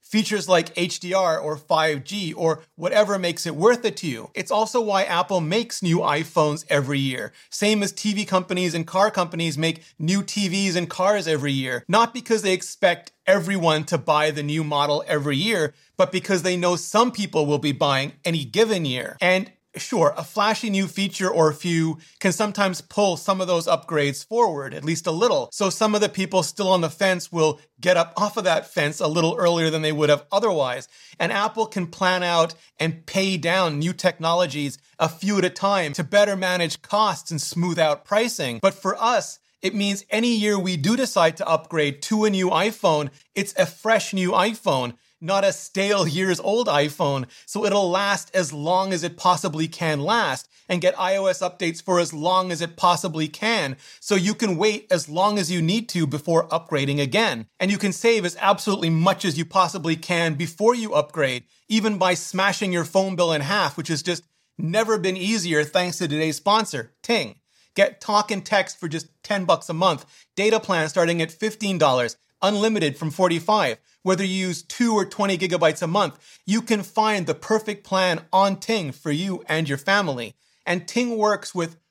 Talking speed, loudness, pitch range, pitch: 195 wpm, -22 LUFS, 160-200 Hz, 180 Hz